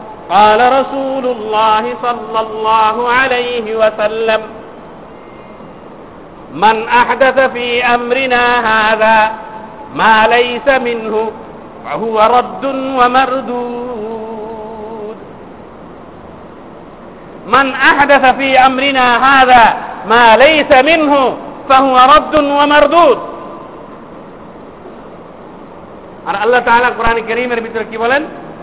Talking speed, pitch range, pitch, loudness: 75 wpm, 220-265 Hz, 245 Hz, -10 LUFS